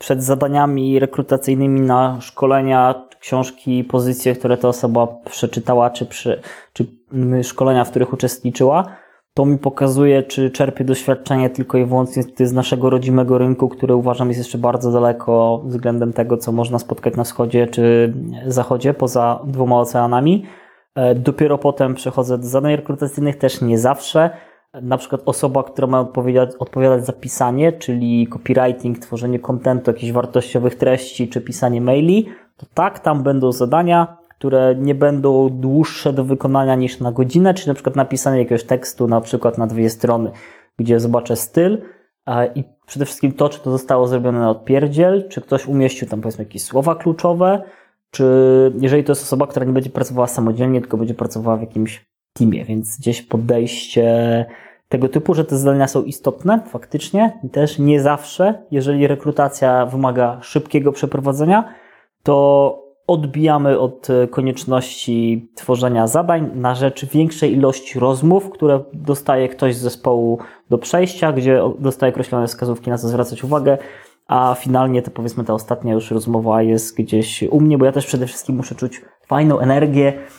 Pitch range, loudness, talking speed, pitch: 120-140 Hz, -17 LUFS, 155 wpm, 130 Hz